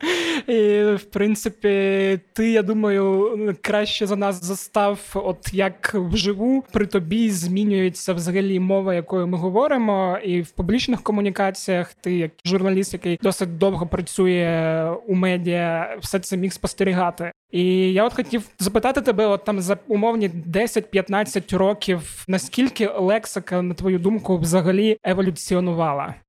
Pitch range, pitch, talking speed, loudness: 185-210 Hz, 195 Hz, 130 wpm, -21 LUFS